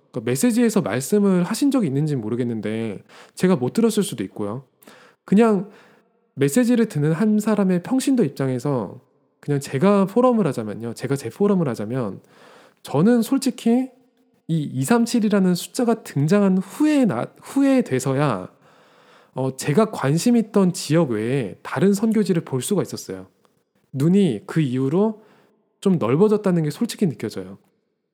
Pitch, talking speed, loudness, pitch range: 190 Hz, 290 characters per minute, -21 LUFS, 135-225 Hz